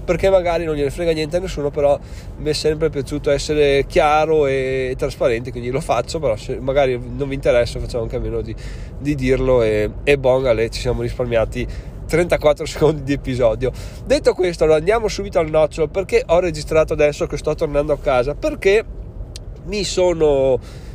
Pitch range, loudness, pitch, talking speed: 125-160 Hz, -18 LUFS, 145 Hz, 180 wpm